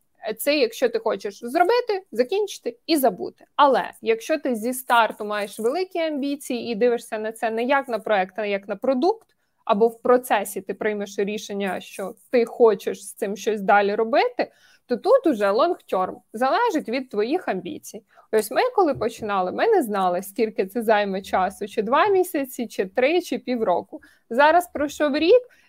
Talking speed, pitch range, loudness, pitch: 170 wpm, 215-310 Hz, -22 LUFS, 240 Hz